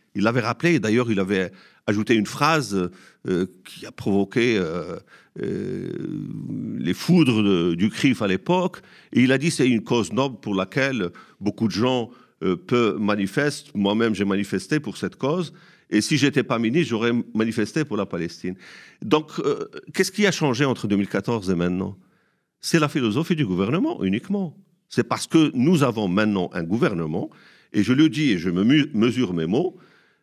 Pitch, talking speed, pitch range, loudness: 120 Hz, 175 wpm, 100-155 Hz, -22 LUFS